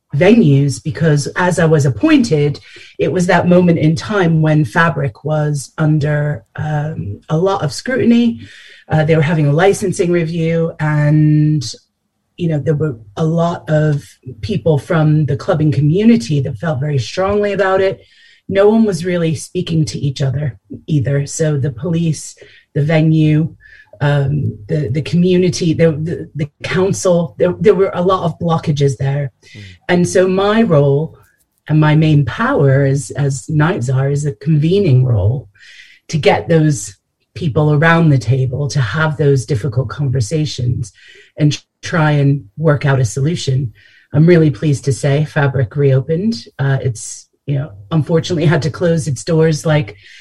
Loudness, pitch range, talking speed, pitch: -14 LUFS, 140-165 Hz, 155 wpm, 155 Hz